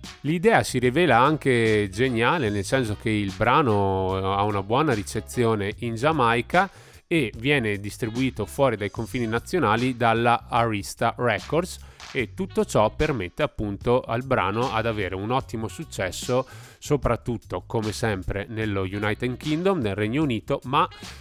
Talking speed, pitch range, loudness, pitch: 135 wpm, 105-130 Hz, -24 LUFS, 115 Hz